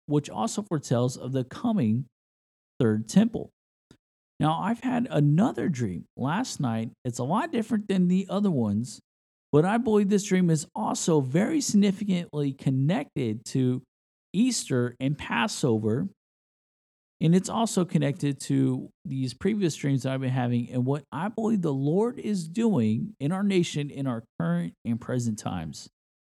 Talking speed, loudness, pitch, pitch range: 150 wpm, -27 LUFS, 150 Hz, 125-195 Hz